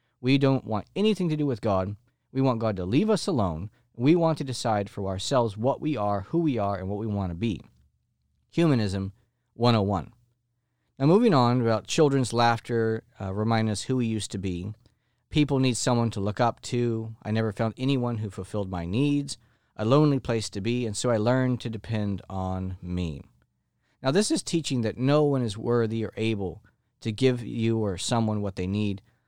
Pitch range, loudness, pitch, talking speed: 105-130 Hz, -26 LUFS, 115 Hz, 195 wpm